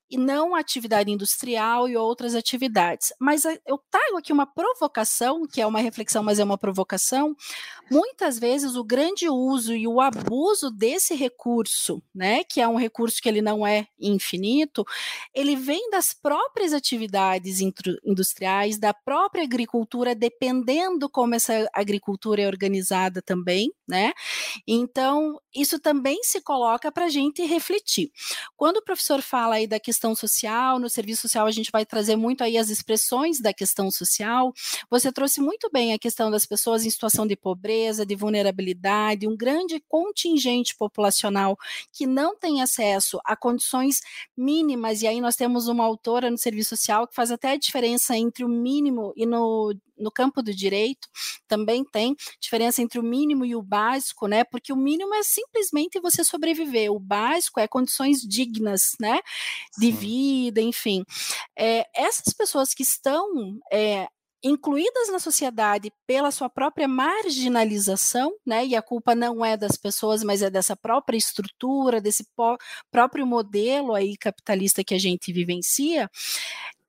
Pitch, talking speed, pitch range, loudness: 235 Hz, 155 wpm, 215-280 Hz, -23 LUFS